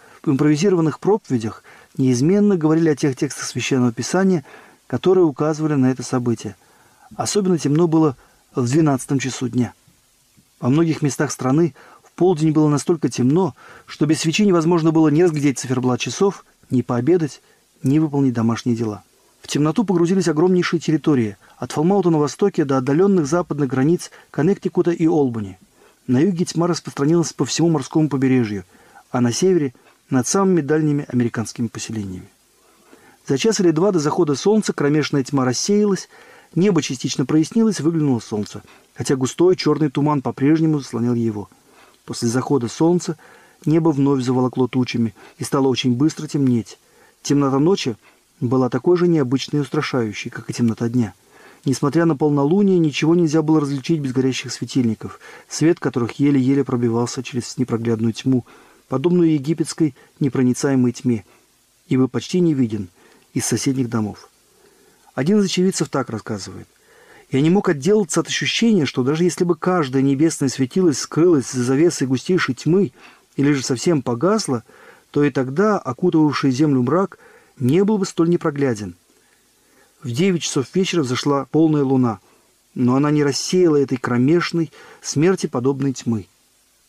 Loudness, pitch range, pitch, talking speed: -19 LUFS, 125-170 Hz, 145 Hz, 145 wpm